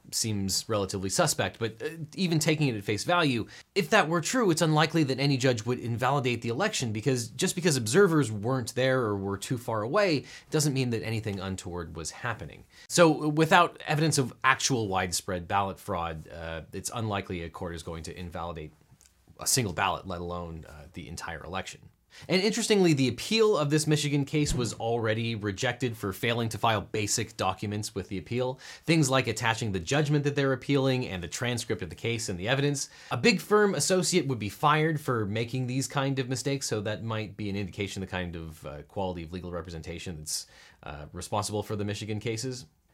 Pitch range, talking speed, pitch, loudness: 100-140 Hz, 195 wpm, 115 Hz, -28 LUFS